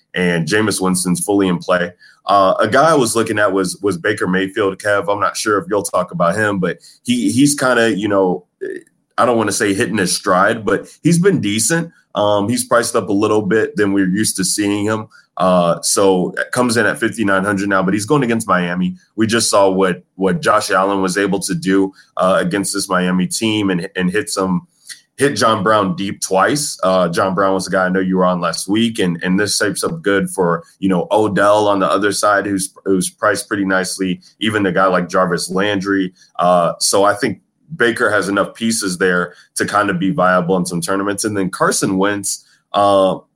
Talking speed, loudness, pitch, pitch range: 215 wpm, -16 LUFS, 95 Hz, 95-105 Hz